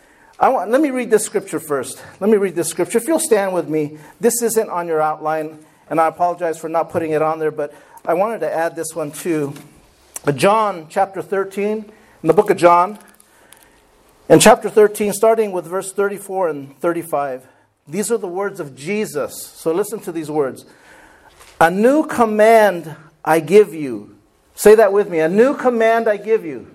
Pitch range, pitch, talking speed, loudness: 160-215 Hz, 180 Hz, 190 wpm, -17 LUFS